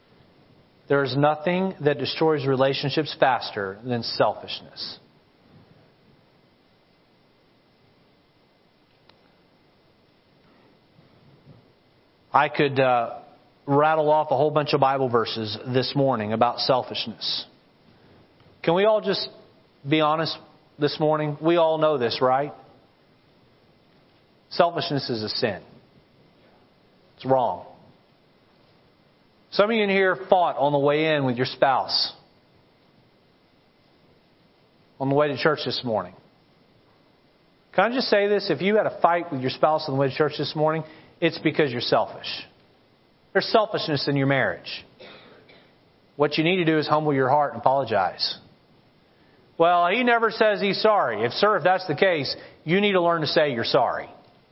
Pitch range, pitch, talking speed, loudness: 135-170 Hz, 150 Hz, 135 wpm, -23 LUFS